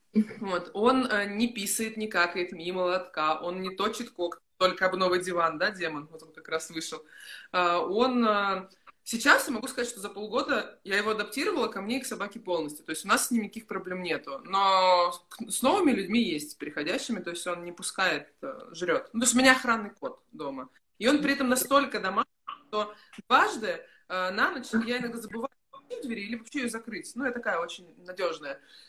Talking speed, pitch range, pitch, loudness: 200 wpm, 180-245 Hz, 205 Hz, -28 LUFS